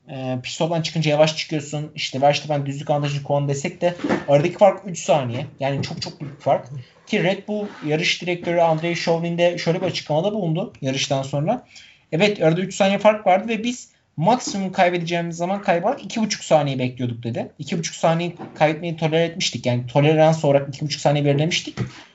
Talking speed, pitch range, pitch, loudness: 170 wpm, 145-180 Hz, 160 Hz, -21 LUFS